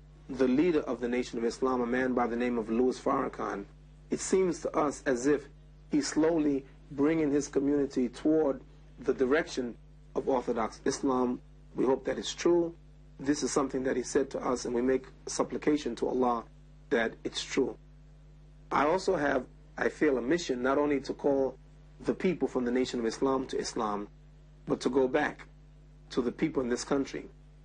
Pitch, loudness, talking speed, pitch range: 145 Hz, -31 LUFS, 180 wpm, 130-150 Hz